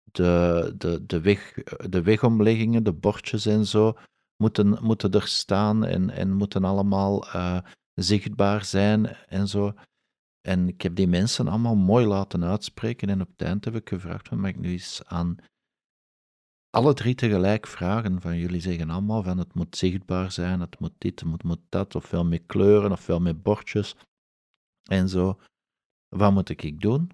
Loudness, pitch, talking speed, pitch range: -24 LUFS, 100 Hz, 170 wpm, 90-105 Hz